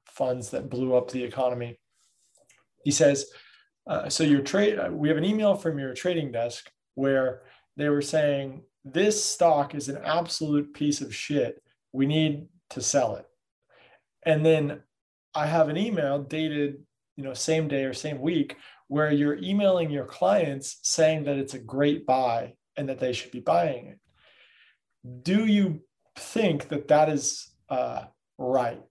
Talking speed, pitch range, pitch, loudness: 160 wpm, 135-160 Hz, 145 Hz, -26 LUFS